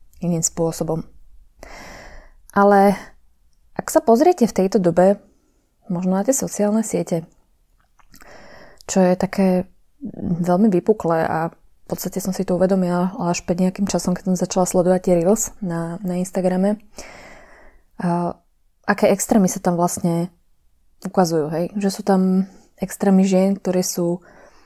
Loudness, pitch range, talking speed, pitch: -19 LUFS, 175-200 Hz, 130 wpm, 185 Hz